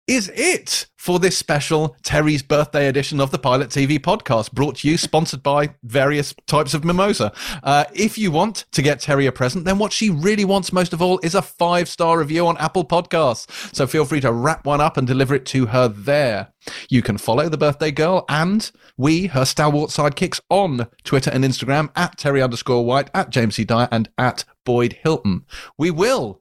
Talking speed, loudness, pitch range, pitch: 200 wpm, -19 LUFS, 135-175 Hz, 150 Hz